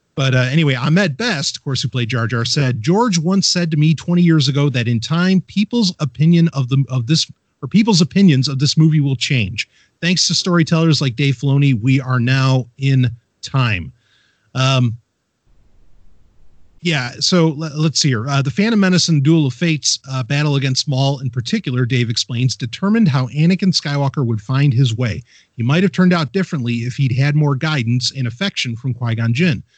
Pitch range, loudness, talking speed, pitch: 125-165 Hz, -16 LUFS, 190 wpm, 140 Hz